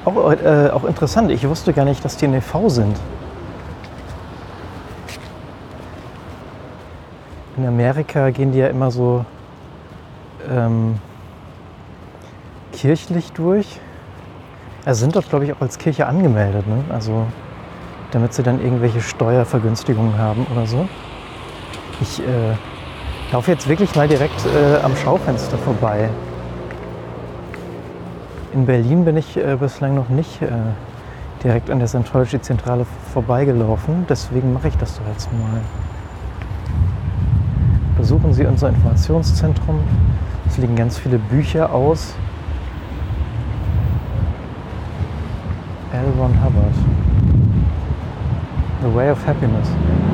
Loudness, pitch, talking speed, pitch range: -18 LUFS, 115 Hz, 110 wpm, 90-130 Hz